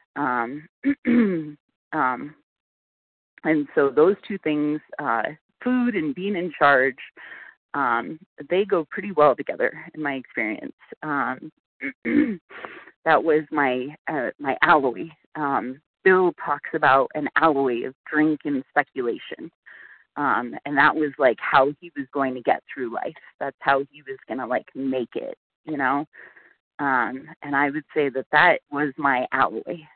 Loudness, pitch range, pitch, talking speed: -23 LUFS, 140-180 Hz, 150 Hz, 145 wpm